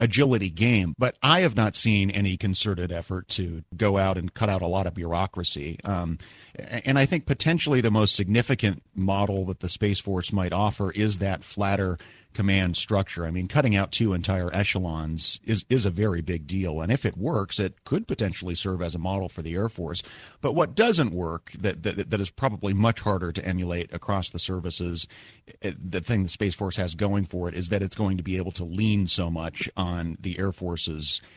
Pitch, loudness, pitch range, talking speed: 95 Hz, -26 LUFS, 90-110 Hz, 210 wpm